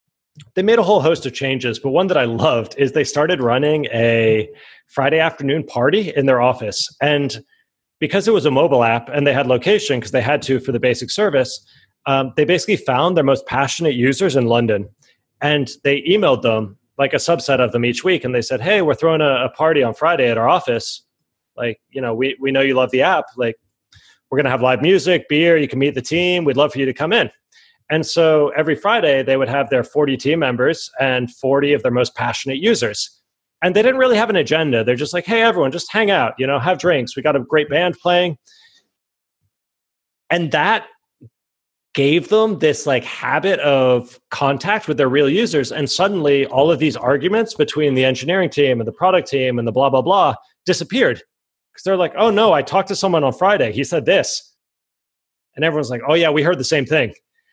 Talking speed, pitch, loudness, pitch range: 215 wpm, 145 Hz, -17 LUFS, 130-175 Hz